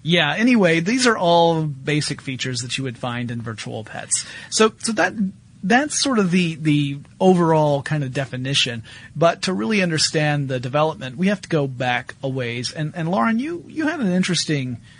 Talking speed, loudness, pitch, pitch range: 190 wpm, -20 LUFS, 155 Hz, 130-185 Hz